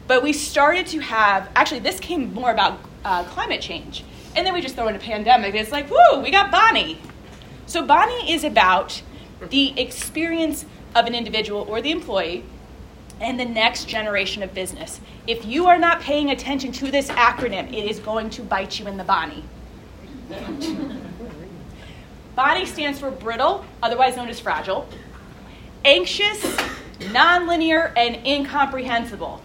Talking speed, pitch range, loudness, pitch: 155 wpm, 230-315 Hz, -20 LUFS, 260 Hz